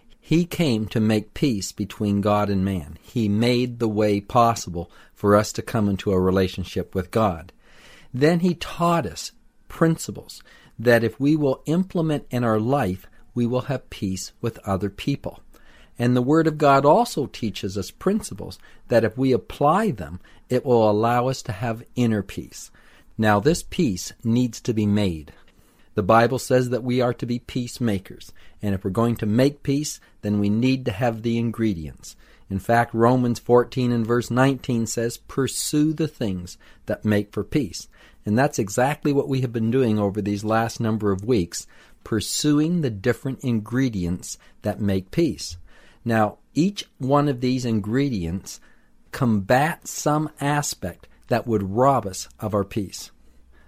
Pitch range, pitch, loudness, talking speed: 105-130 Hz, 115 Hz, -23 LUFS, 165 wpm